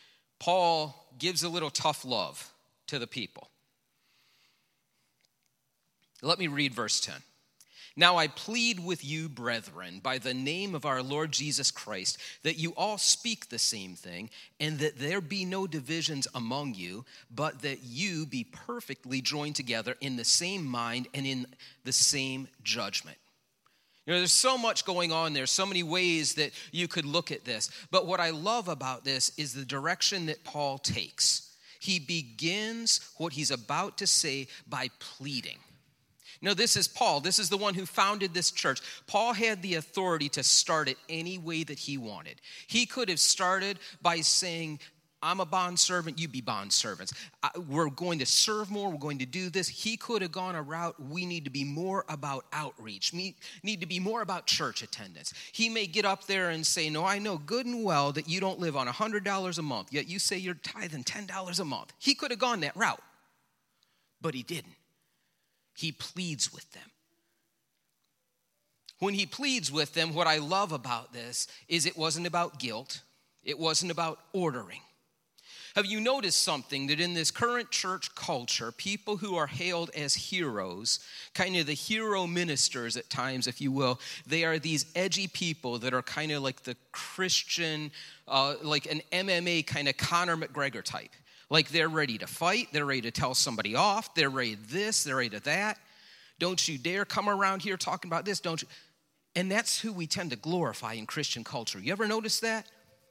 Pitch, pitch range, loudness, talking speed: 165 Hz, 140-185 Hz, -30 LUFS, 185 wpm